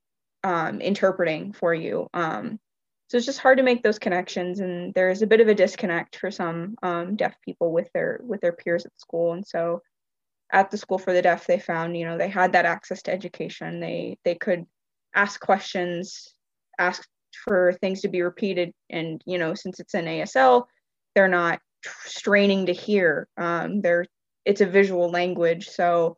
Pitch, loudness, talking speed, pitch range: 180 Hz, -24 LUFS, 185 wpm, 170-205 Hz